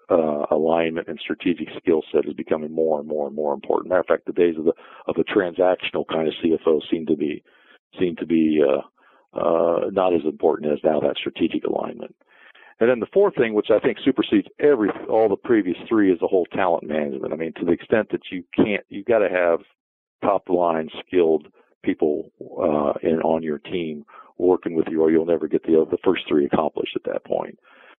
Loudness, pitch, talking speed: -22 LUFS, 85 Hz, 210 wpm